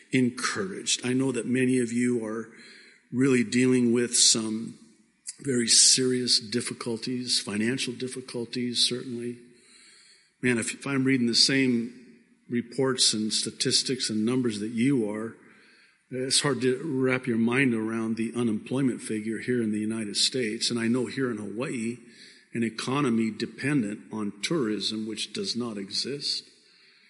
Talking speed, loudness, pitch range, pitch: 140 wpm, -26 LUFS, 115-130 Hz, 120 Hz